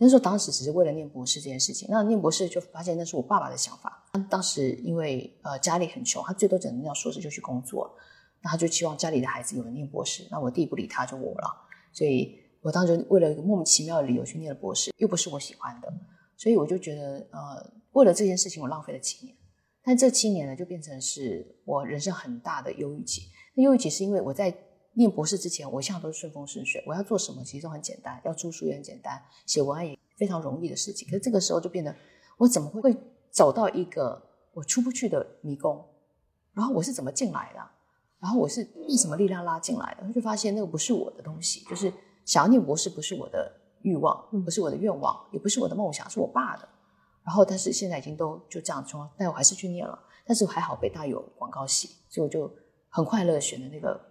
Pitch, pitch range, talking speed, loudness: 180 Hz, 155-205 Hz, 360 characters per minute, -27 LUFS